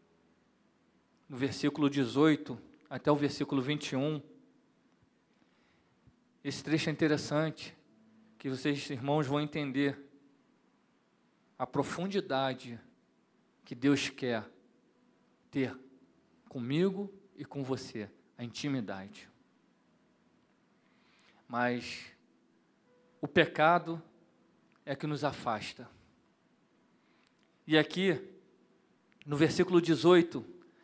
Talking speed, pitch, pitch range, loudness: 80 wpm, 145 Hz, 130-160 Hz, -32 LUFS